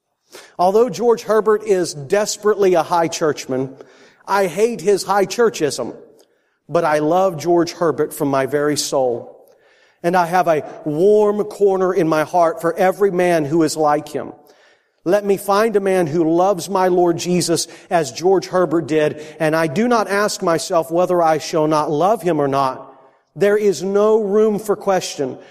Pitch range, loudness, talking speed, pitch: 160-205 Hz, -17 LUFS, 170 wpm, 180 Hz